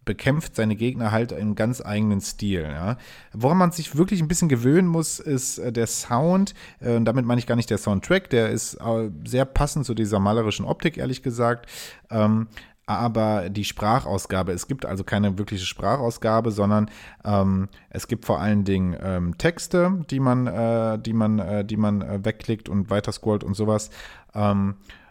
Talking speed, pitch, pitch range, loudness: 160 wpm, 110 Hz, 105-125 Hz, -23 LUFS